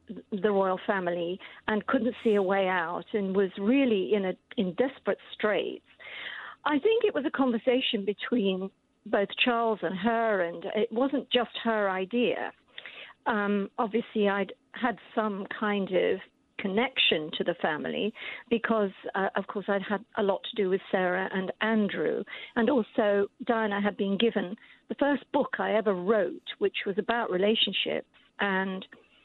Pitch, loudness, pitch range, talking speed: 215 Hz, -28 LUFS, 195-235 Hz, 155 wpm